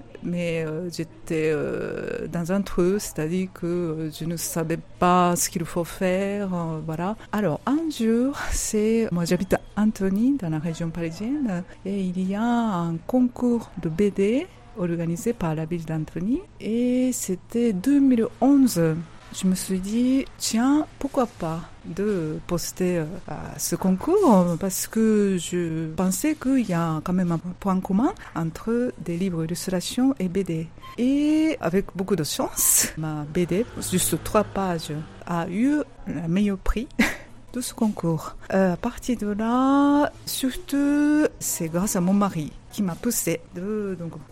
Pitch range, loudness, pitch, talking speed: 170-235 Hz, -24 LUFS, 190 Hz, 155 wpm